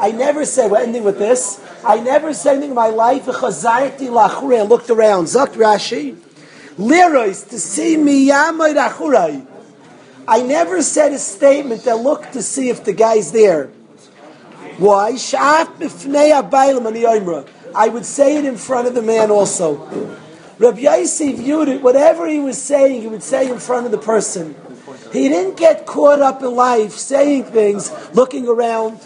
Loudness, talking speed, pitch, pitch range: -14 LUFS, 175 wpm, 250 Hz, 220-285 Hz